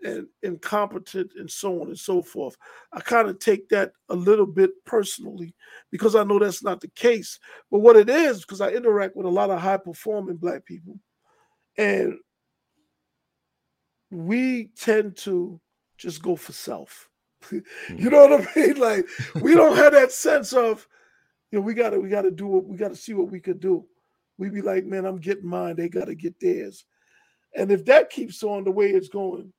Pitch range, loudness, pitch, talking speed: 185-255 Hz, -21 LUFS, 205 Hz, 190 wpm